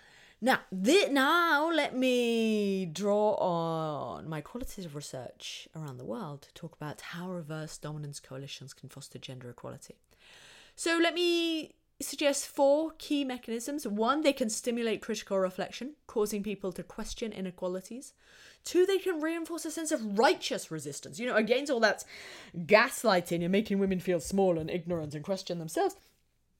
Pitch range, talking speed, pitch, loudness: 170-275 Hz, 150 wpm, 210 Hz, -30 LUFS